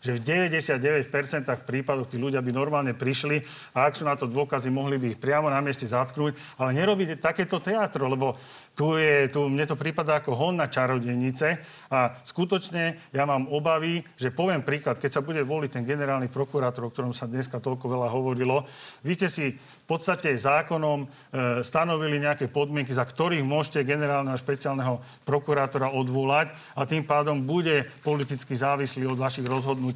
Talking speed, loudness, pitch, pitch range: 170 wpm, -26 LUFS, 140 Hz, 130-155 Hz